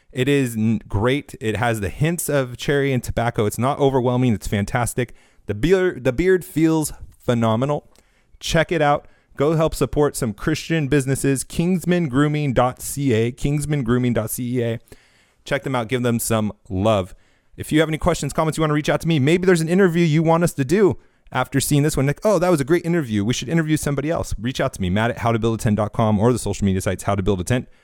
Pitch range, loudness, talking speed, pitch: 115-155 Hz, -20 LUFS, 205 wpm, 135 Hz